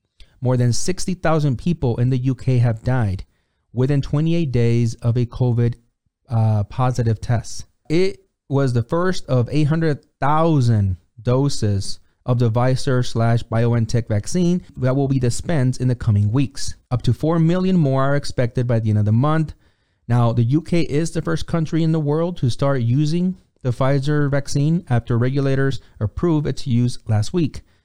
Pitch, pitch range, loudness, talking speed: 130 Hz, 120-150 Hz, -20 LUFS, 160 wpm